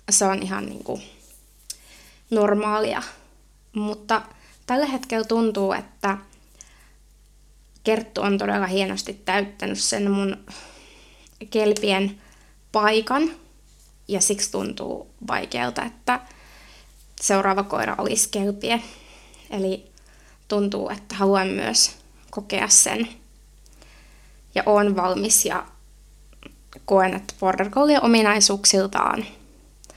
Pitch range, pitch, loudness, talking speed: 195-225 Hz, 205 Hz, -21 LUFS, 90 wpm